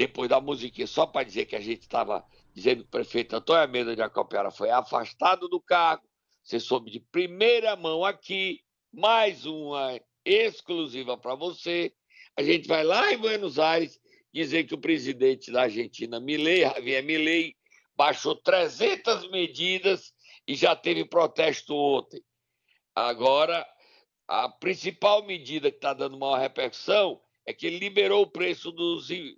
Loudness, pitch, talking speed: -26 LUFS, 185 Hz, 150 wpm